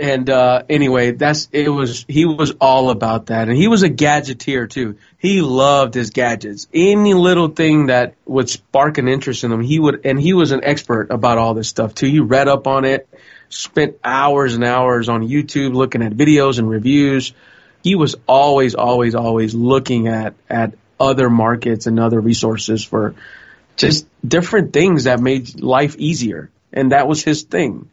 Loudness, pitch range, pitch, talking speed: -15 LUFS, 115-145 Hz, 130 Hz, 185 wpm